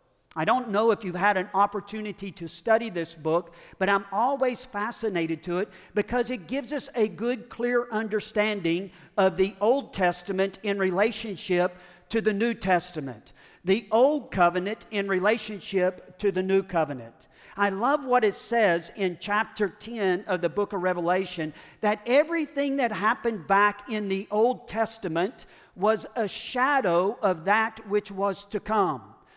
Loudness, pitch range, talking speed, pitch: -26 LUFS, 185-225 Hz, 155 wpm, 205 Hz